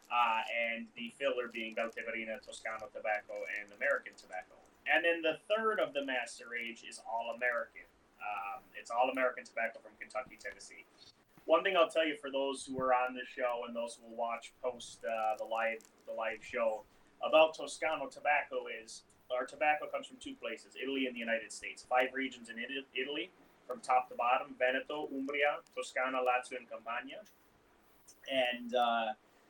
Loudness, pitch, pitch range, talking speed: -36 LUFS, 125 Hz, 115-145 Hz, 175 wpm